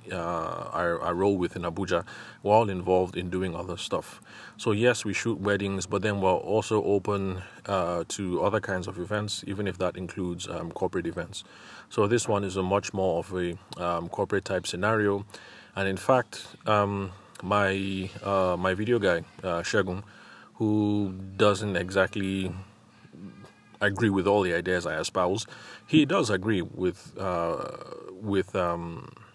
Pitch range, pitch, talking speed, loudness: 90-105 Hz, 95 Hz, 155 wpm, -28 LUFS